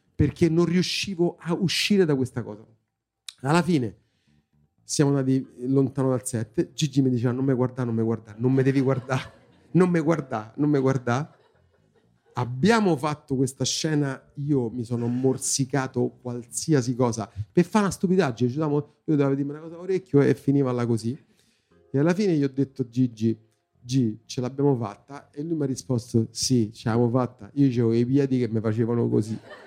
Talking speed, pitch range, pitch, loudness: 170 wpm, 120-145 Hz, 130 Hz, -24 LUFS